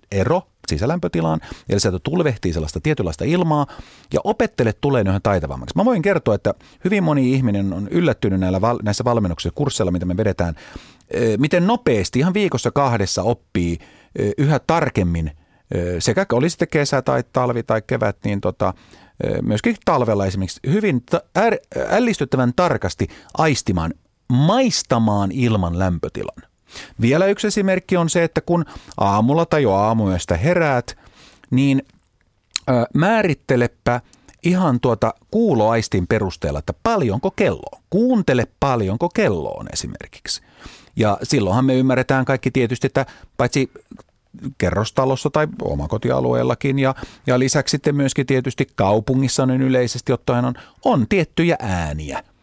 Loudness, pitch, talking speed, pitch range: -19 LUFS, 125 Hz, 125 wpm, 100-150 Hz